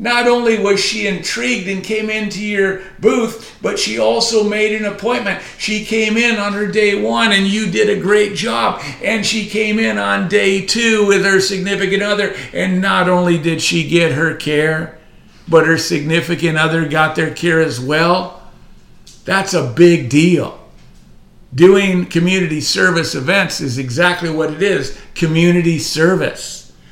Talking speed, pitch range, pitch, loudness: 160 wpm, 165-205 Hz, 185 Hz, -14 LUFS